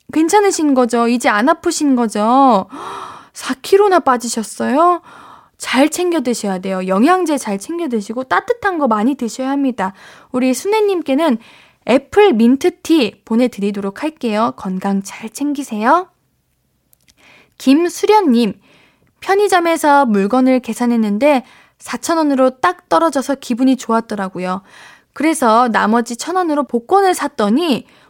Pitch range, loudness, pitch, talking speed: 230-325 Hz, -15 LUFS, 260 Hz, 275 characters per minute